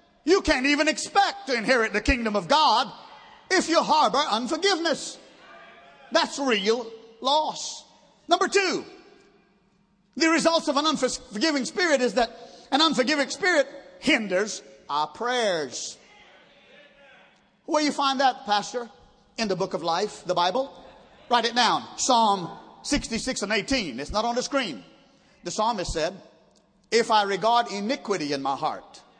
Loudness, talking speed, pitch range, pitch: -24 LUFS, 140 wpm, 210-295 Hz, 250 Hz